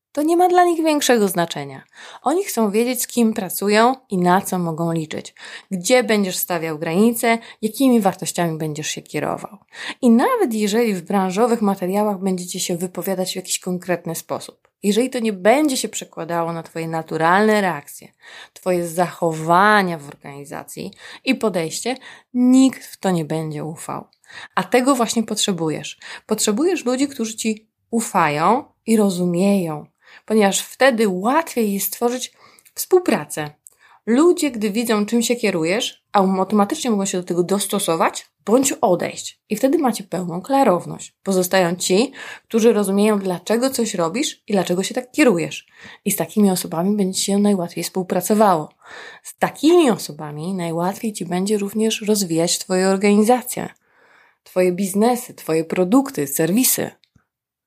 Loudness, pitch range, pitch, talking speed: -19 LUFS, 180-235 Hz, 205 Hz, 140 wpm